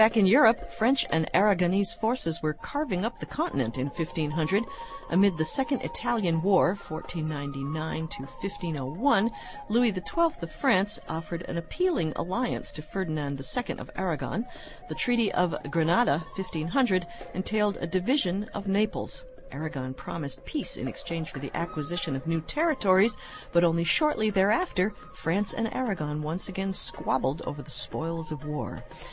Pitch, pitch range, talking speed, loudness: 180 Hz, 155-215 Hz, 140 wpm, -28 LUFS